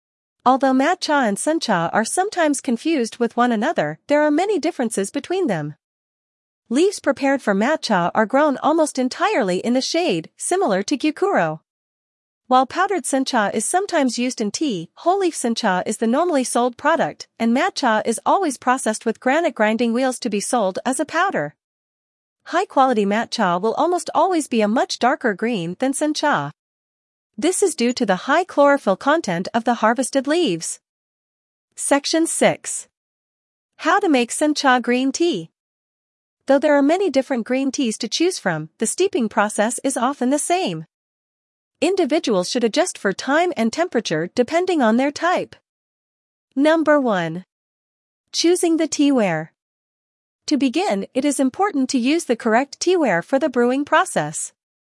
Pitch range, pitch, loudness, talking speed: 225-315 Hz, 265 Hz, -19 LUFS, 155 wpm